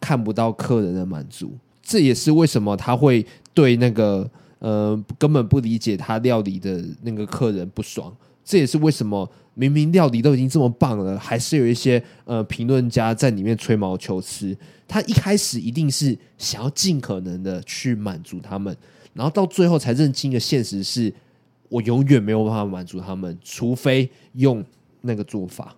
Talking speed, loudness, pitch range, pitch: 270 characters per minute, -20 LUFS, 105-135 Hz, 120 Hz